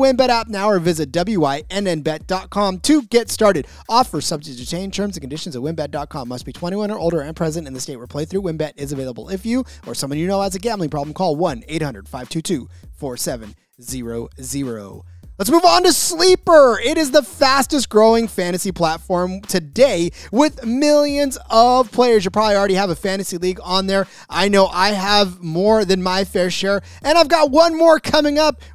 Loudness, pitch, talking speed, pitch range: -17 LUFS, 190 Hz, 190 wpm, 155-235 Hz